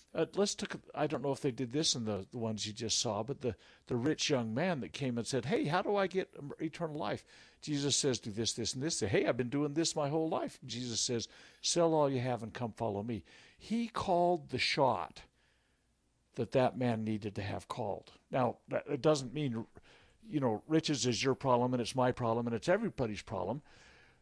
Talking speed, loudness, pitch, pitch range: 220 wpm, -35 LUFS, 130 Hz, 115-155 Hz